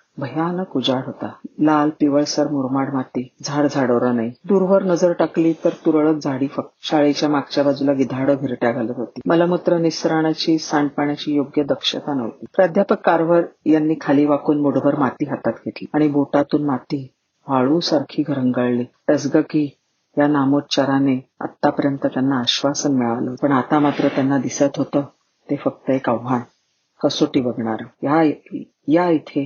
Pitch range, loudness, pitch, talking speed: 135-155 Hz, -19 LUFS, 145 Hz, 130 wpm